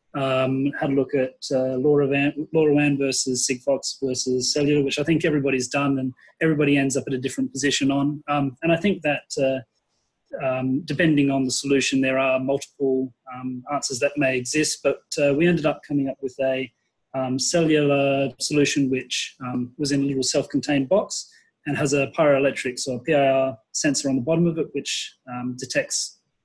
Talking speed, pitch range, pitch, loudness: 190 wpm, 130-145 Hz, 140 Hz, -22 LUFS